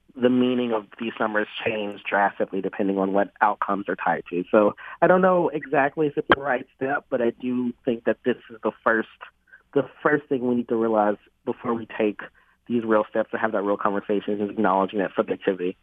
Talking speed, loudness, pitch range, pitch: 210 wpm, -24 LUFS, 100-125 Hz, 110 Hz